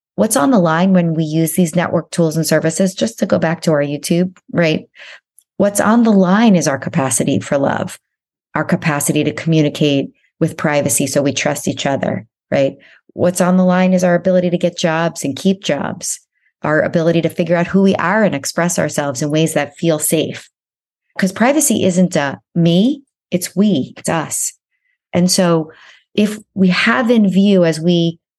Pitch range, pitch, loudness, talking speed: 160-190 Hz, 175 Hz, -15 LUFS, 185 wpm